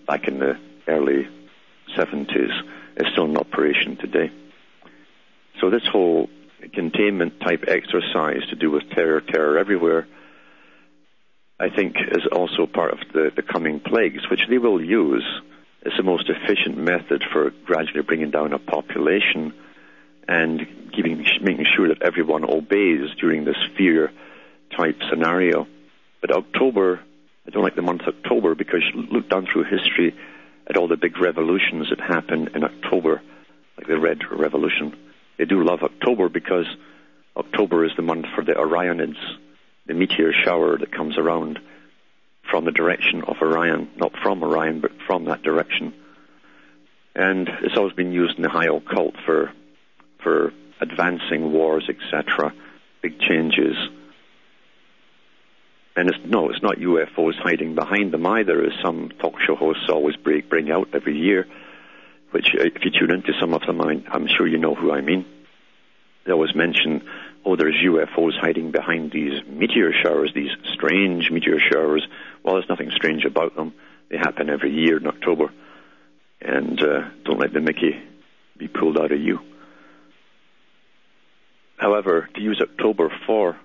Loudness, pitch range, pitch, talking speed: -21 LUFS, 60-85 Hz, 75 Hz, 150 wpm